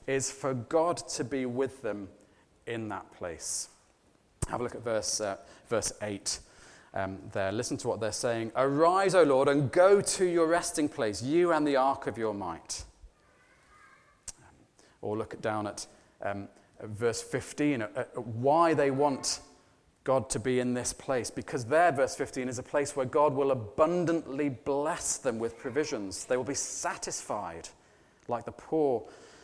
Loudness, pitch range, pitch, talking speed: -30 LUFS, 105-145 Hz, 130 Hz, 165 wpm